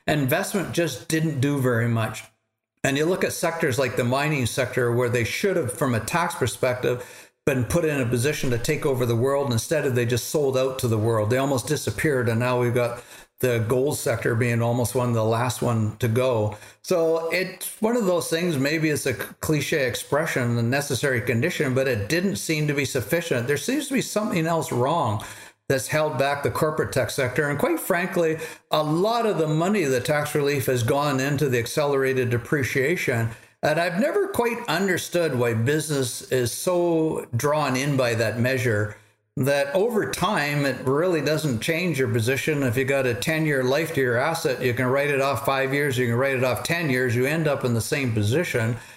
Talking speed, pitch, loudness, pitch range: 205 wpm, 135 Hz, -23 LUFS, 120-155 Hz